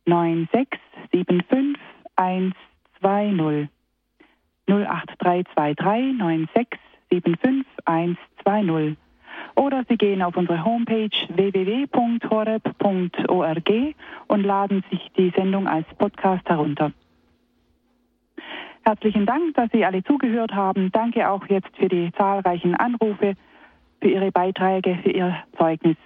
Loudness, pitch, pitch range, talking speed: -22 LUFS, 195 Hz, 180-225 Hz, 90 wpm